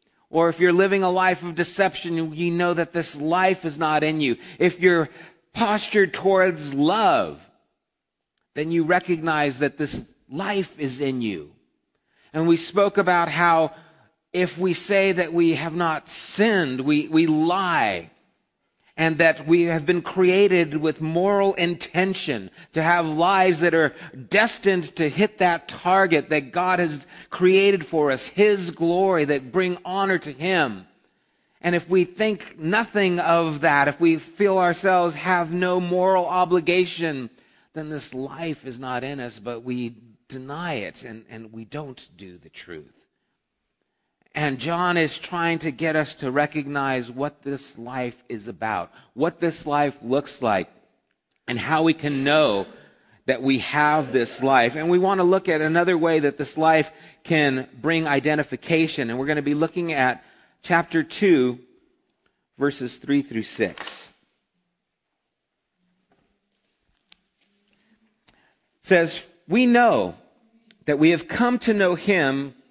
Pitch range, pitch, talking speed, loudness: 145-180 Hz, 165 Hz, 150 wpm, -22 LUFS